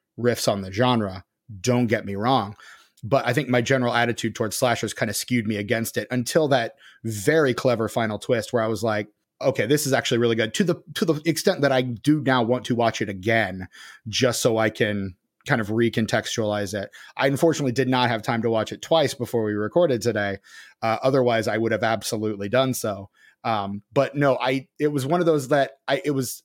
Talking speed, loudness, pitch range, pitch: 215 wpm, -23 LUFS, 110-135 Hz, 120 Hz